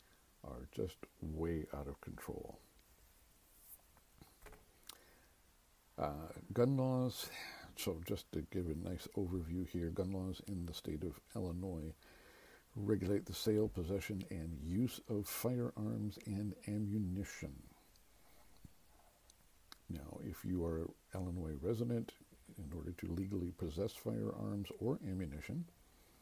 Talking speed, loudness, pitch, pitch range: 110 wpm, -43 LUFS, 95 Hz, 85-105 Hz